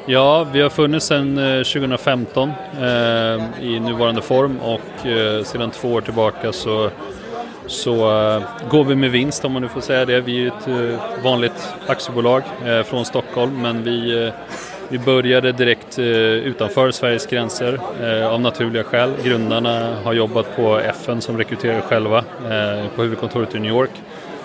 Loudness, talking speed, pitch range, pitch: -18 LUFS, 160 wpm, 115-130 Hz, 120 Hz